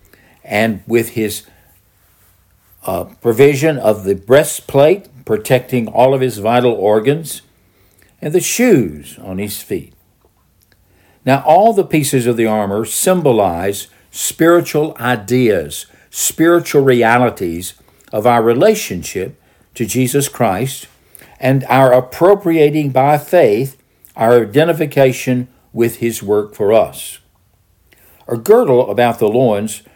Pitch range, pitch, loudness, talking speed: 105-140 Hz, 120 Hz, -14 LUFS, 110 wpm